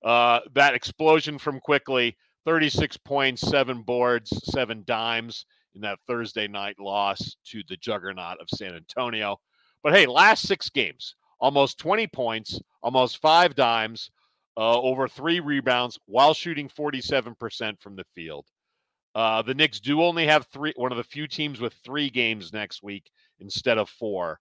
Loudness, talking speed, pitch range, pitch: -24 LUFS, 160 wpm, 110-150 Hz, 125 Hz